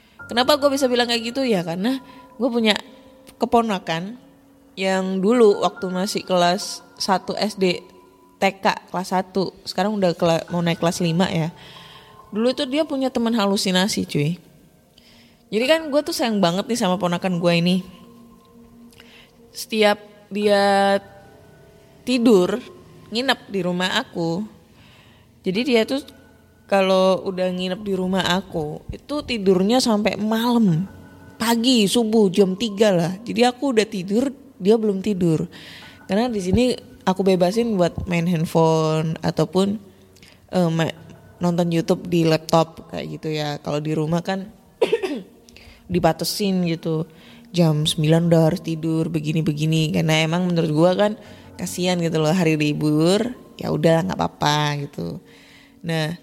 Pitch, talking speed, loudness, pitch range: 190 Hz, 130 wpm, -21 LUFS, 165-220 Hz